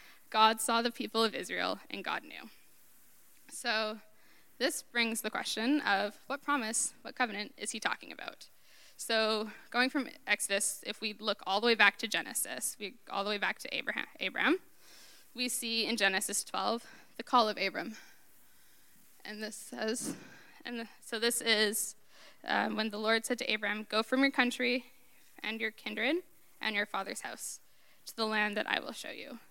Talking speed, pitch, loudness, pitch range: 175 wpm, 225 Hz, -33 LUFS, 215-250 Hz